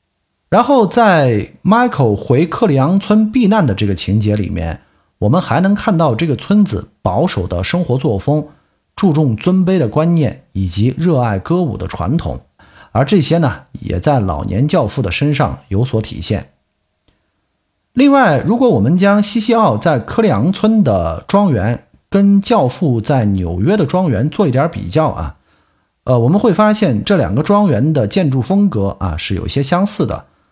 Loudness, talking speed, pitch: -14 LUFS, 255 characters per minute, 150 Hz